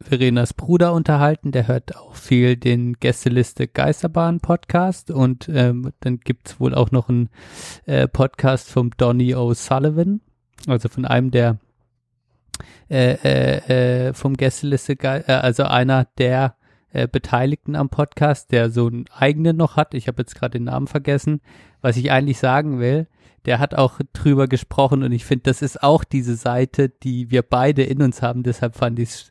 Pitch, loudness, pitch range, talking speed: 130 Hz, -19 LUFS, 120-140 Hz, 165 wpm